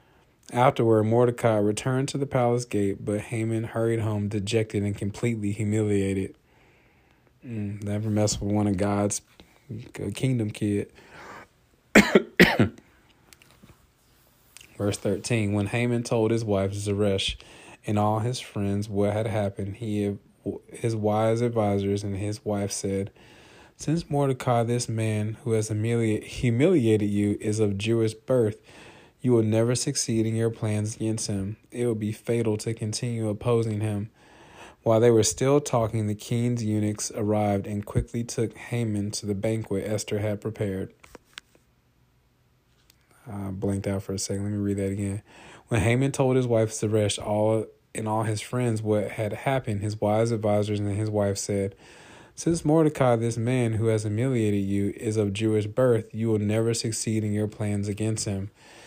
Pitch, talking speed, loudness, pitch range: 110 Hz, 150 wpm, -26 LUFS, 105-115 Hz